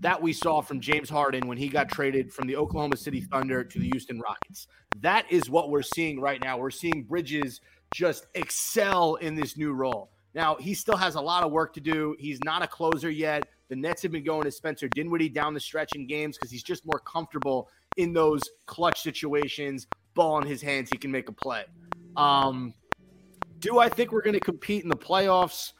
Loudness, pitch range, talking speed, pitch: -28 LUFS, 140-170 Hz, 215 wpm, 150 Hz